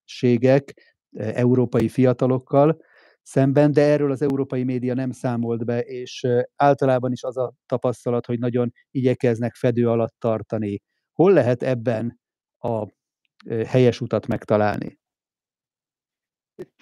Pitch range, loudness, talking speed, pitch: 115-130 Hz, -21 LUFS, 110 wpm, 125 Hz